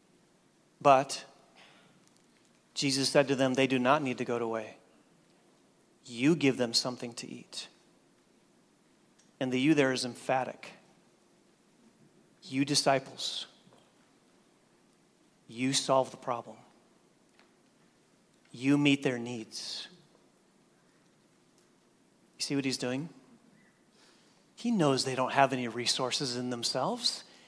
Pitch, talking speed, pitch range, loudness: 130 Hz, 105 wpm, 125-140 Hz, -30 LUFS